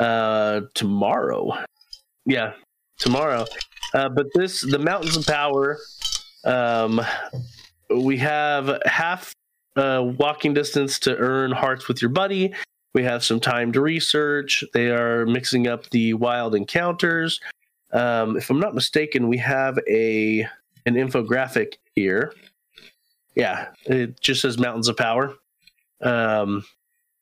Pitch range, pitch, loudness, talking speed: 120-145 Hz, 130 Hz, -22 LUFS, 125 wpm